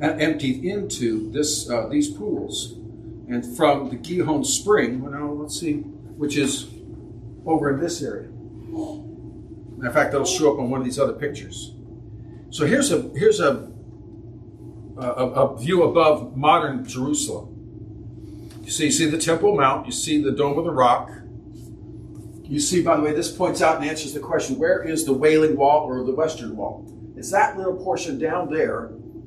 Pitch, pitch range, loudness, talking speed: 140 Hz, 115-155 Hz, -22 LUFS, 170 wpm